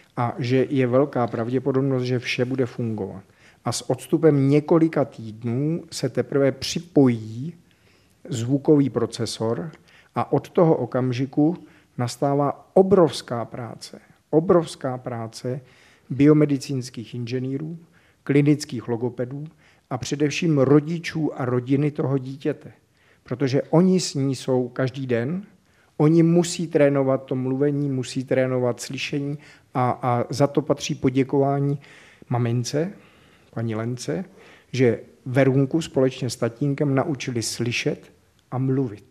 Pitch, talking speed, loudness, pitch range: 135 Hz, 110 wpm, -23 LUFS, 125-150 Hz